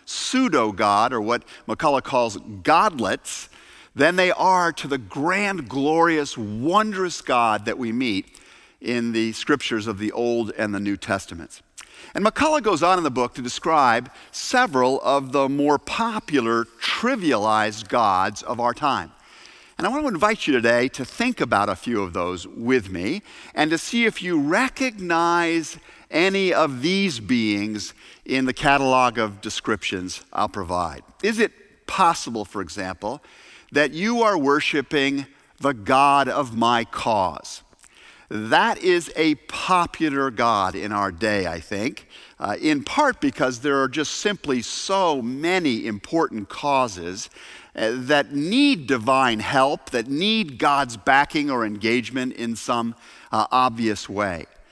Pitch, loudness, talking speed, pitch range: 140 Hz, -22 LUFS, 145 wpm, 115-180 Hz